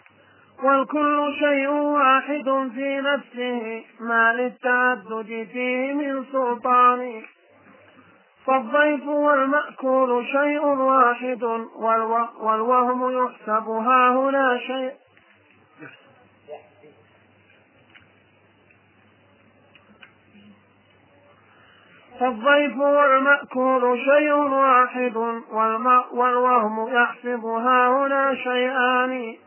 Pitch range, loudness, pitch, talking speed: 225-270 Hz, -20 LUFS, 250 Hz, 55 wpm